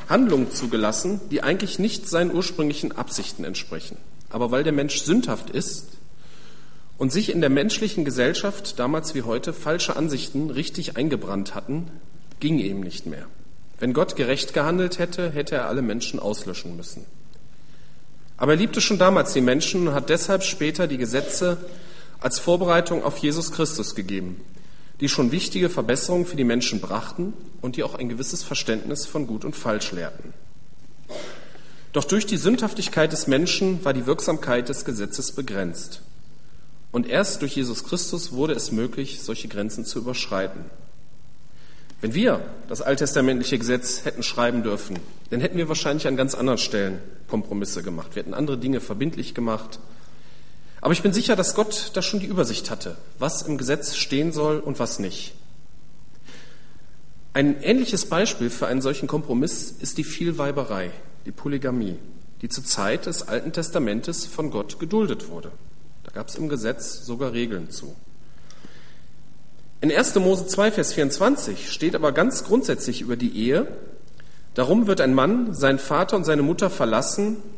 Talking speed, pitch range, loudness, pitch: 155 wpm, 120-175 Hz, -23 LUFS, 145 Hz